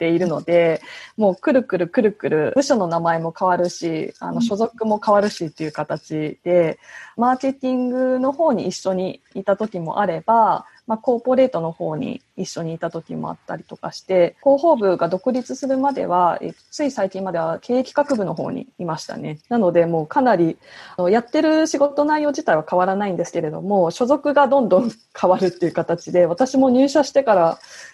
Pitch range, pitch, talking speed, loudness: 170-260 Hz, 200 Hz, 375 characters per minute, -19 LUFS